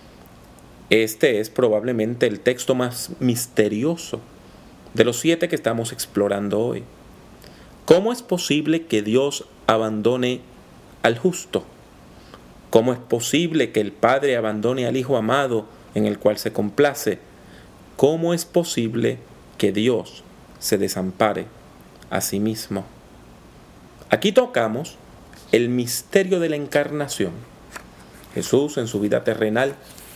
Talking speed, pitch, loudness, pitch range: 115 wpm, 125 Hz, -21 LUFS, 110-150 Hz